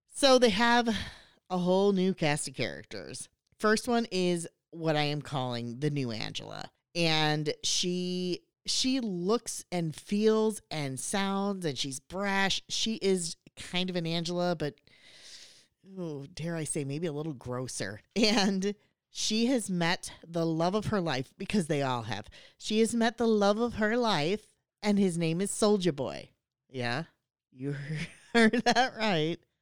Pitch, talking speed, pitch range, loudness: 180 Hz, 155 wpm, 150-210 Hz, -30 LUFS